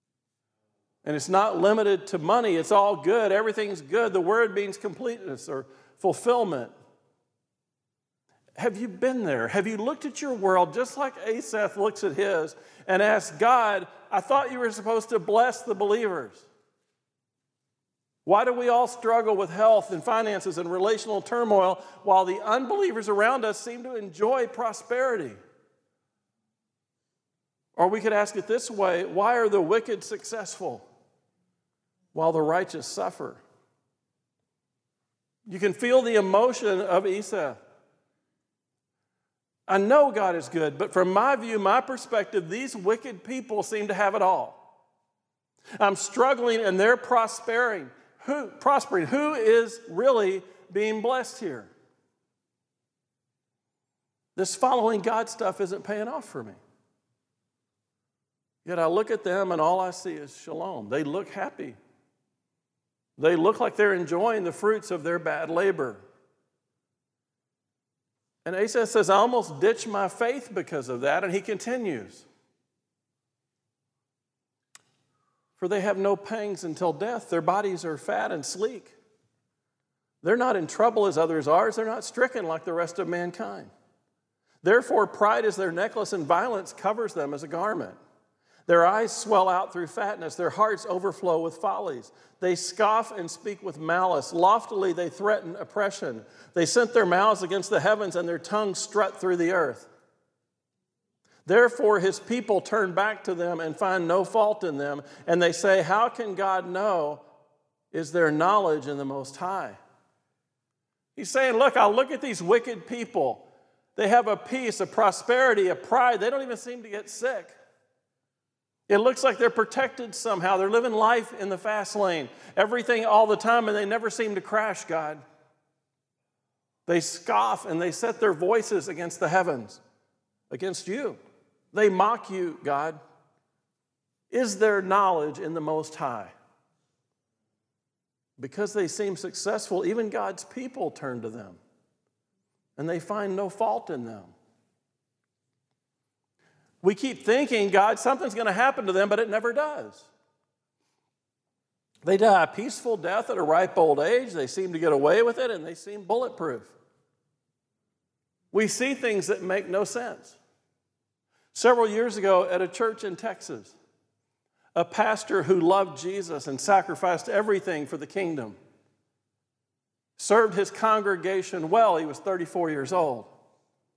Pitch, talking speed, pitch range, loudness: 205 Hz, 150 wpm, 180-235 Hz, -25 LUFS